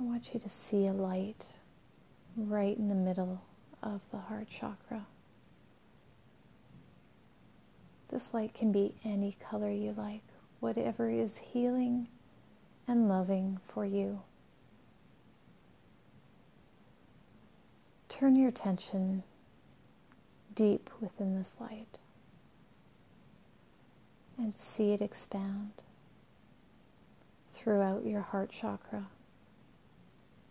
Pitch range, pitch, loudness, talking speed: 190-220 Hz, 200 Hz, -35 LUFS, 90 wpm